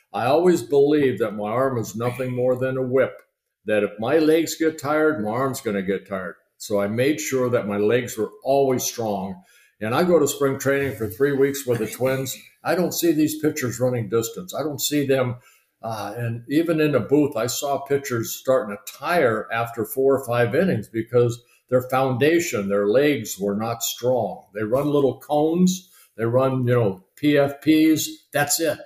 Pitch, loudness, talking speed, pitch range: 130 Hz, -22 LUFS, 195 wpm, 115-145 Hz